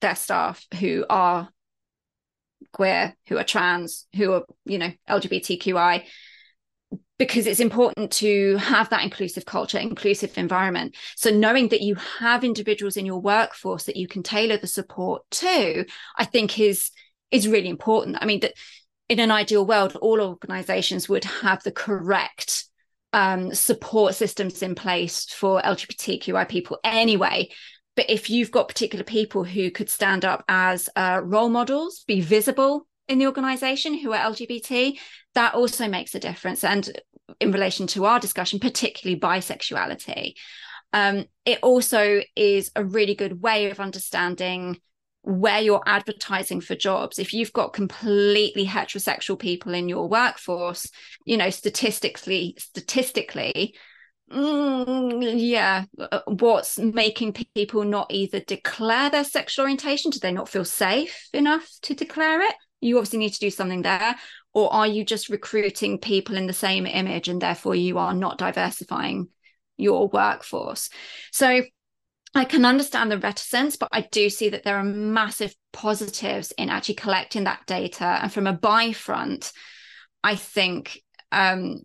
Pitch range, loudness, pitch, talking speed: 195-235 Hz, -23 LUFS, 210 Hz, 145 wpm